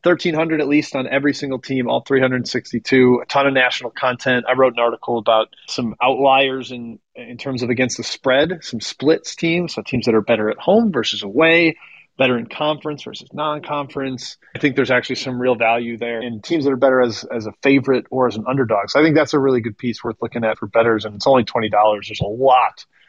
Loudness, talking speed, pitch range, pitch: -18 LUFS, 225 wpm, 115-140 Hz, 130 Hz